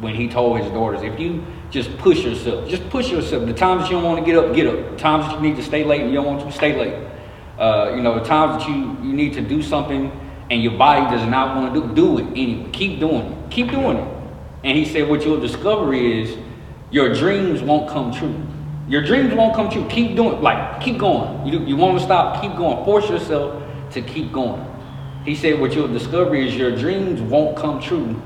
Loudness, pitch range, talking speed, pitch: -19 LUFS, 130-170 Hz, 240 wpm, 150 Hz